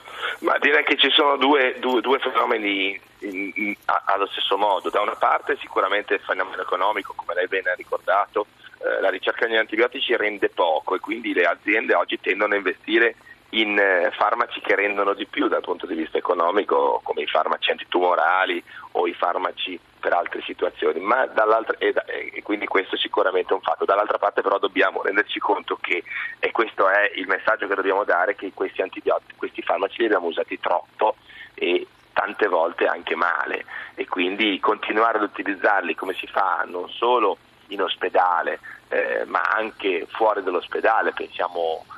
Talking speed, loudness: 175 wpm, -22 LUFS